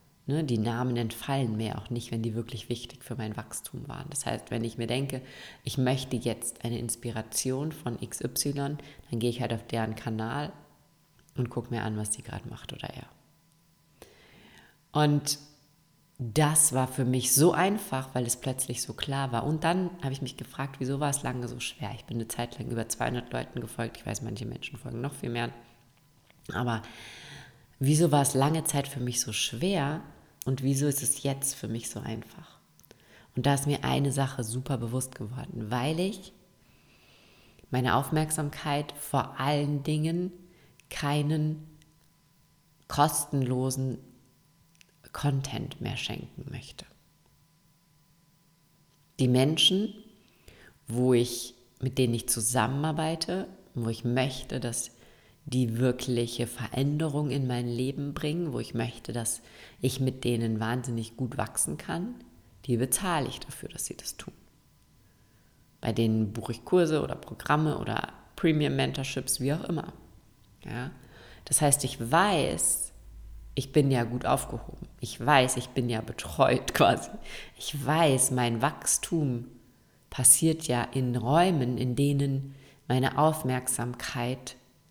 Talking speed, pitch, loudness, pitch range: 145 wpm, 130 Hz, -29 LUFS, 120-145 Hz